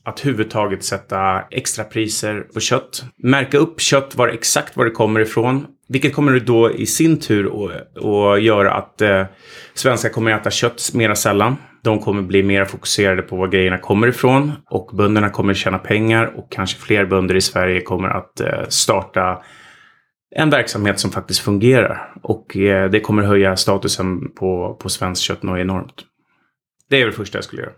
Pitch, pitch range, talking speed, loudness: 105 Hz, 95-120 Hz, 180 wpm, -17 LUFS